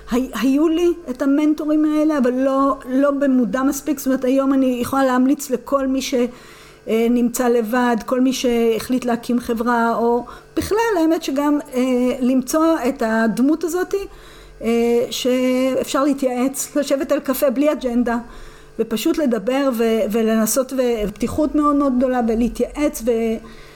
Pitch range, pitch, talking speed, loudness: 240-285 Hz, 260 Hz, 135 wpm, -19 LUFS